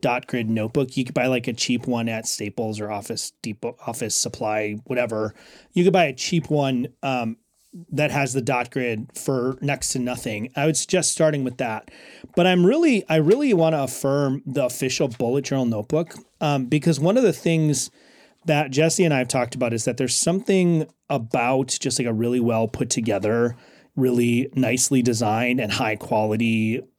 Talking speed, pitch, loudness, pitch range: 185 wpm, 130 Hz, -22 LUFS, 120-155 Hz